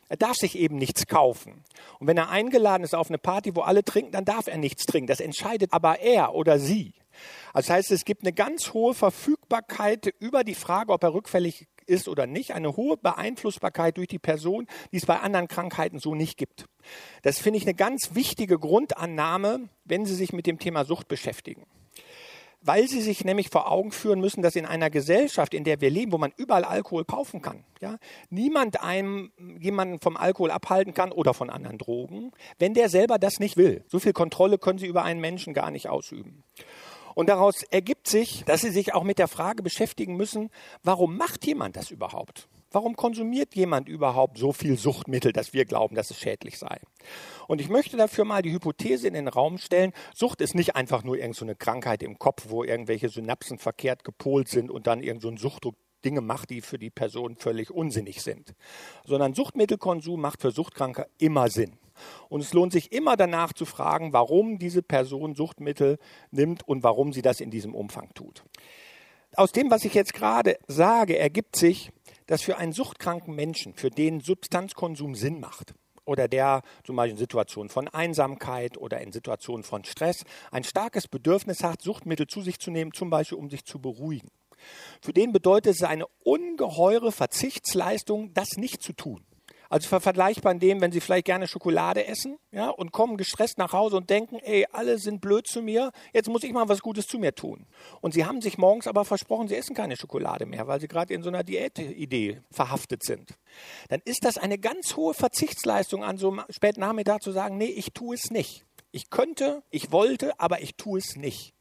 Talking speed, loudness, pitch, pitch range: 200 wpm, -26 LUFS, 180 Hz, 145-210 Hz